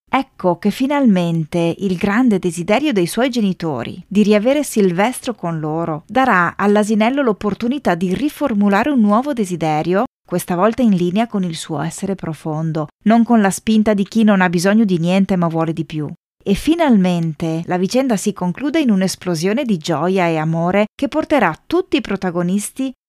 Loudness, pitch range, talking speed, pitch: -17 LUFS, 175-225 Hz, 165 wpm, 195 Hz